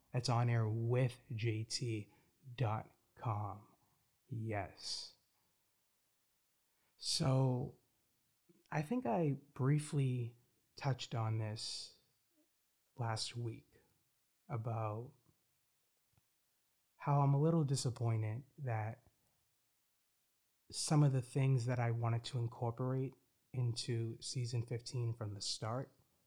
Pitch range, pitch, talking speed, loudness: 115-130 Hz, 120 Hz, 85 wpm, -39 LUFS